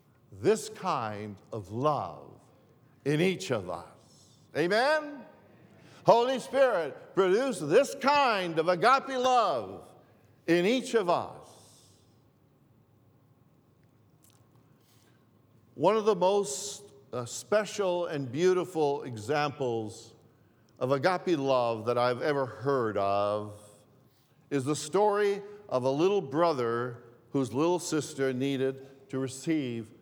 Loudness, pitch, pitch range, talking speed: -29 LUFS, 135 Hz, 120-180 Hz, 100 wpm